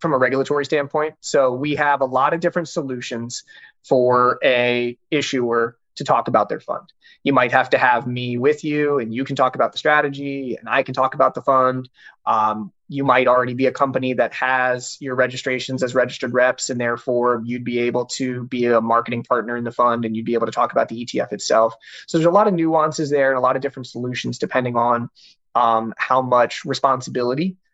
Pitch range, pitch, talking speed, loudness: 120-140 Hz, 130 Hz, 210 wpm, -19 LUFS